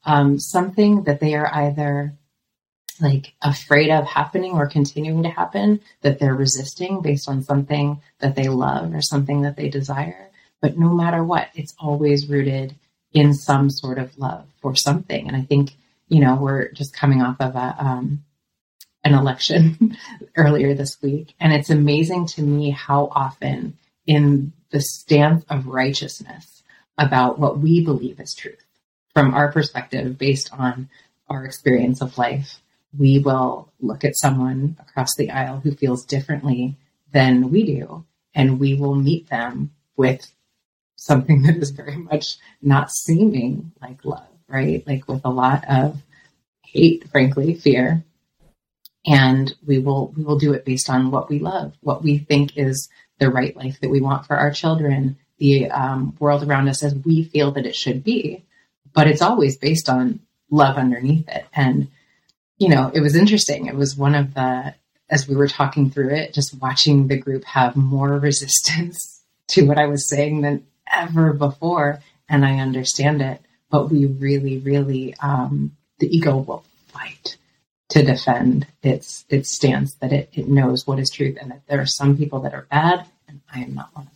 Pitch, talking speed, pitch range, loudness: 145 Hz, 170 wpm, 135-150 Hz, -19 LUFS